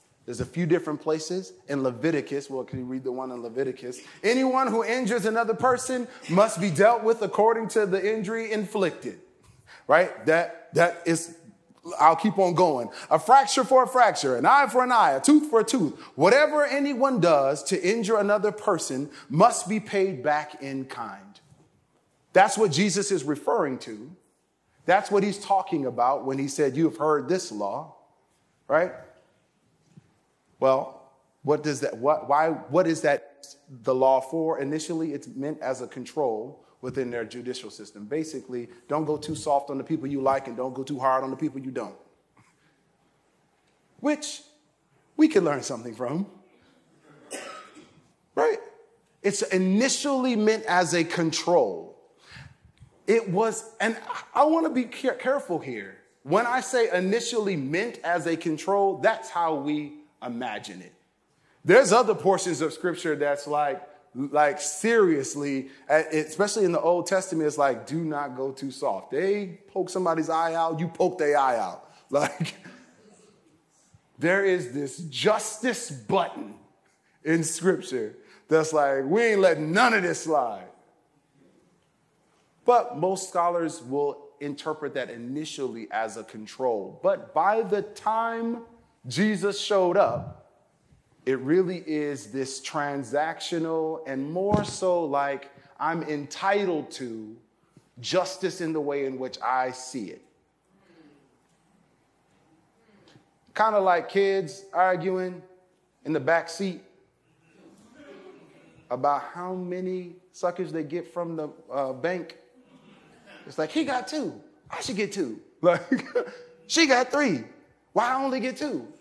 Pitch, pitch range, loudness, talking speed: 175 Hz, 145-215 Hz, -25 LUFS, 145 wpm